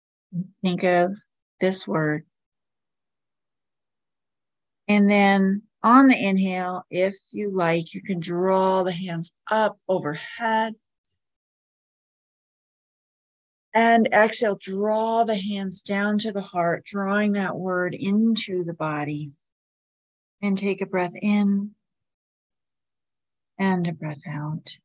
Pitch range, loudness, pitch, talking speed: 170-205 Hz, -23 LUFS, 190 Hz, 105 wpm